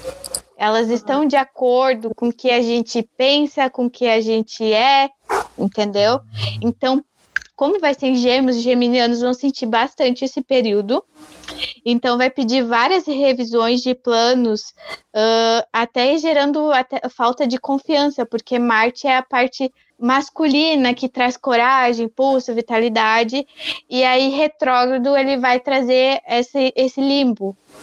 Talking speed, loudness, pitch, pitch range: 140 wpm, -17 LUFS, 255 Hz, 235-270 Hz